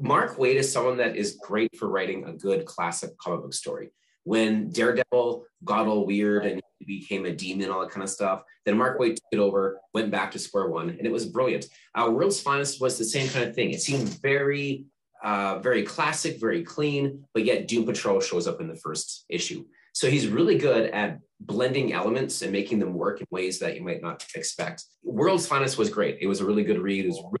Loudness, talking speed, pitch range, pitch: -26 LUFS, 225 wpm, 100-145 Hz, 120 Hz